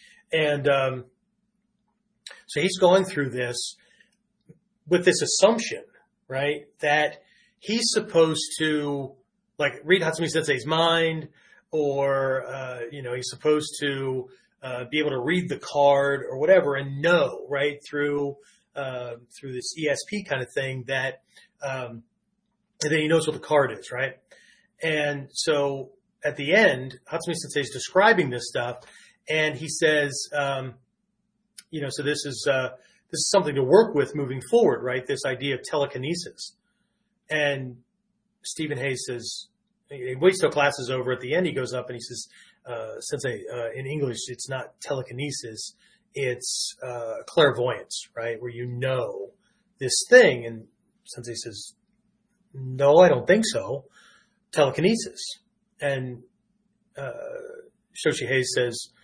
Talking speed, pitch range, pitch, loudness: 145 wpm, 130-195 Hz, 145 Hz, -24 LUFS